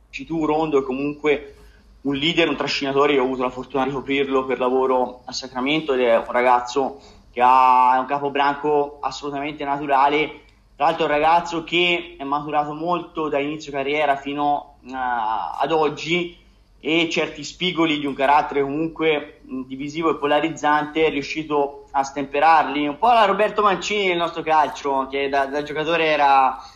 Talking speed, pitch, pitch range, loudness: 165 wpm, 145 Hz, 135-155 Hz, -20 LUFS